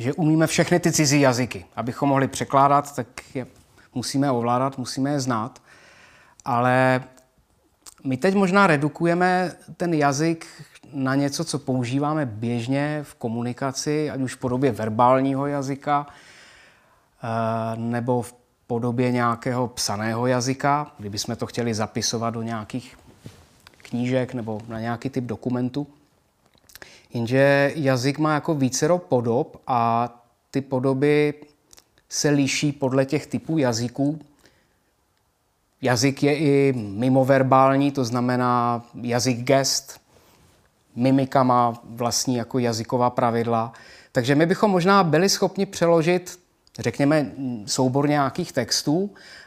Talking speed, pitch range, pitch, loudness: 115 wpm, 120-145 Hz, 130 Hz, -22 LUFS